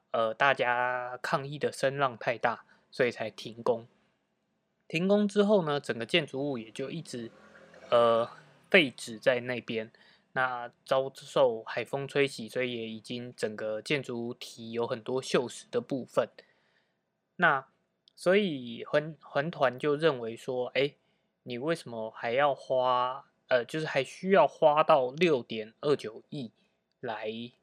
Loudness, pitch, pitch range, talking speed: -30 LUFS, 130 Hz, 120-150 Hz, 200 characters per minute